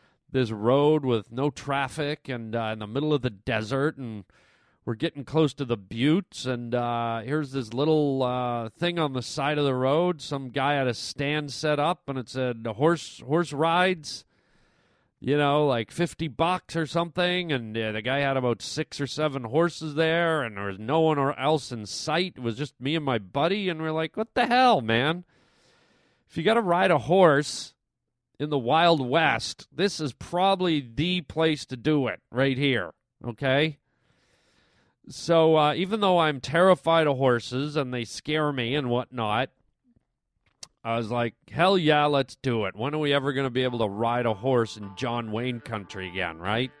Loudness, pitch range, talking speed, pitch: -26 LUFS, 120-160 Hz, 190 wpm, 140 Hz